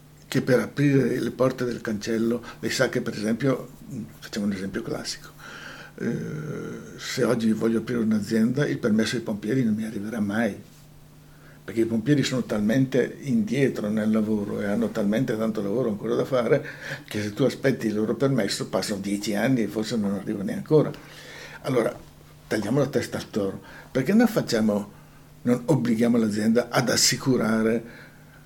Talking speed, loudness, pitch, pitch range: 160 wpm, -25 LUFS, 115 Hz, 110-130 Hz